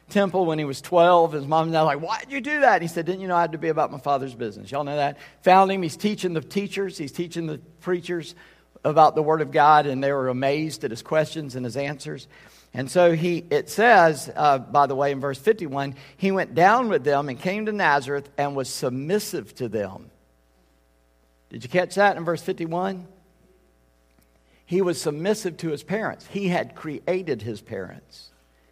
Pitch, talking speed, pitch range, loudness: 155 Hz, 210 wpm, 135-180 Hz, -23 LUFS